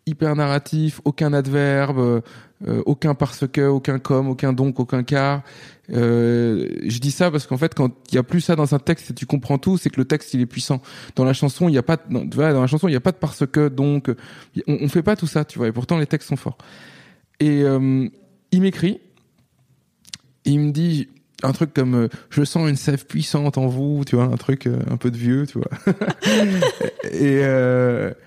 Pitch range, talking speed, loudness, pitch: 130-155 Hz, 215 wpm, -20 LUFS, 140 Hz